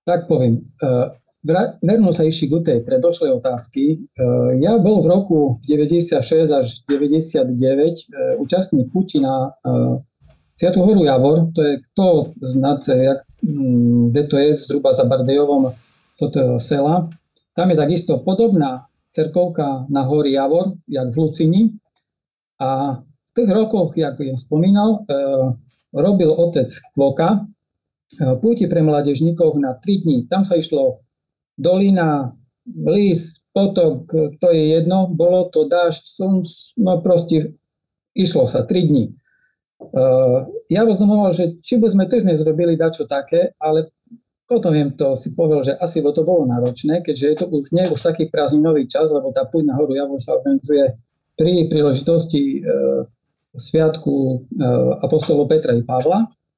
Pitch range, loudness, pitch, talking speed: 135-175 Hz, -17 LUFS, 155 Hz, 135 wpm